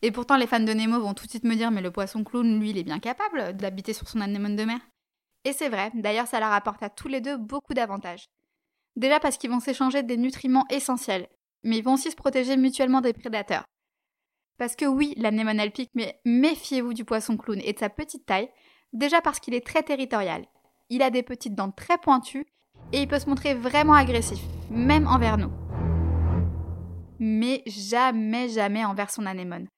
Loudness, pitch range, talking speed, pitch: -25 LUFS, 205-270 Hz, 205 wpm, 235 Hz